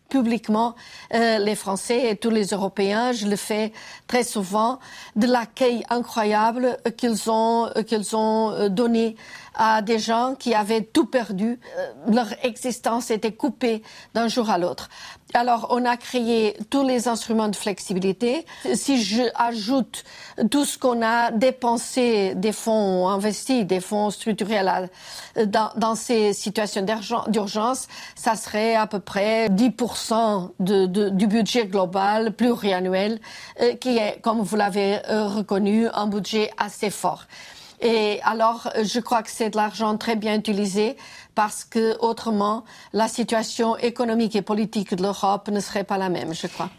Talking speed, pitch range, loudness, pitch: 145 wpm, 210-235 Hz, -23 LUFS, 225 Hz